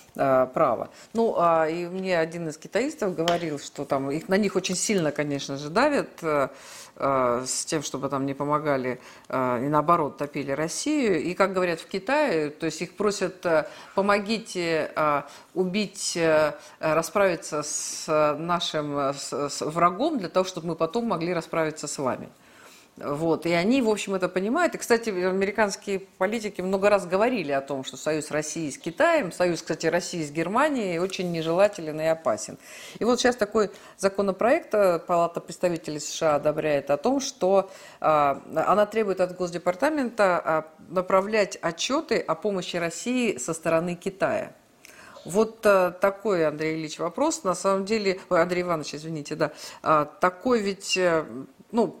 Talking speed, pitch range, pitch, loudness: 150 wpm, 155-200 Hz, 175 Hz, -25 LUFS